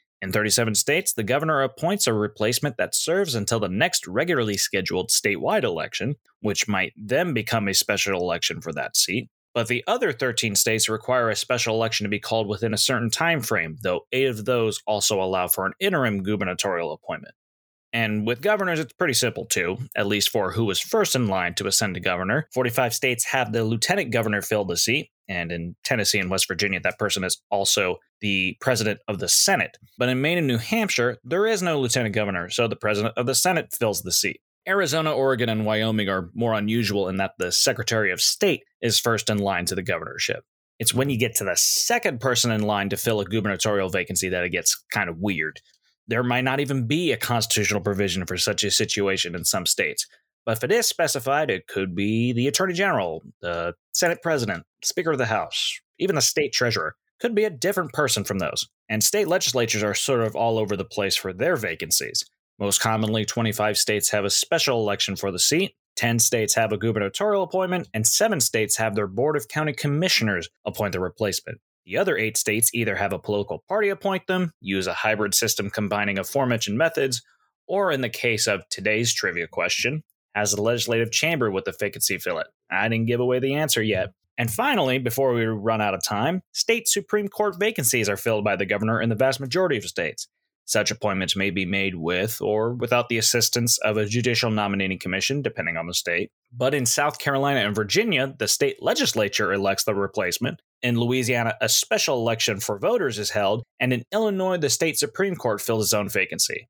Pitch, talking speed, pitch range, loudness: 115 Hz, 205 wpm, 105-130 Hz, -23 LUFS